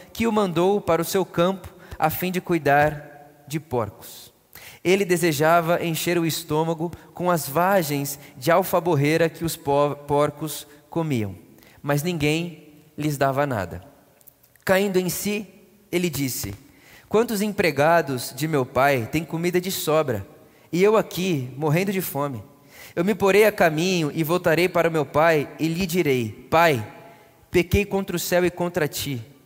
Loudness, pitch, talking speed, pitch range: -22 LUFS, 160 Hz, 150 wpm, 145-180 Hz